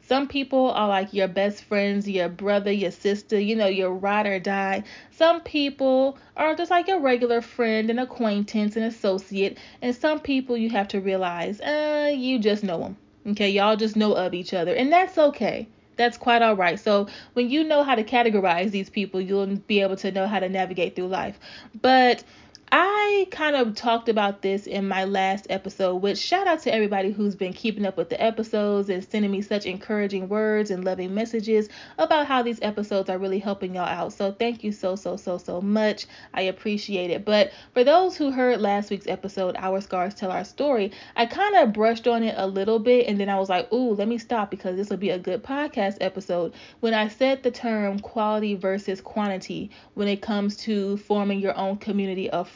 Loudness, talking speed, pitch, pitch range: -24 LUFS, 210 wpm, 205 Hz, 195-240 Hz